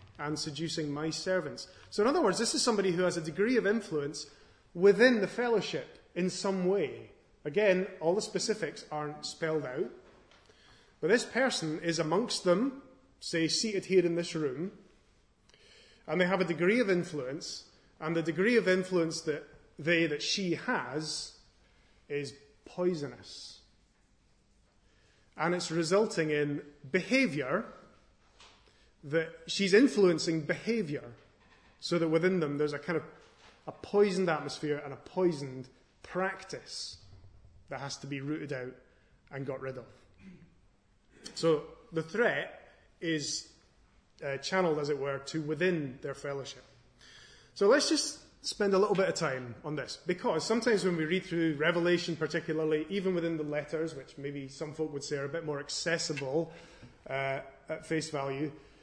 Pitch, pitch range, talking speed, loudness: 160 Hz, 145-185 Hz, 150 wpm, -32 LUFS